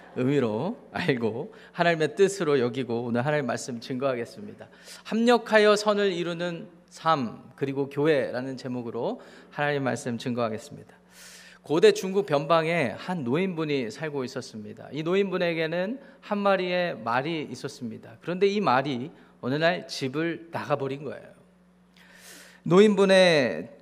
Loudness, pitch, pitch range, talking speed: -26 LUFS, 160 Hz, 135-185 Hz, 310 characters per minute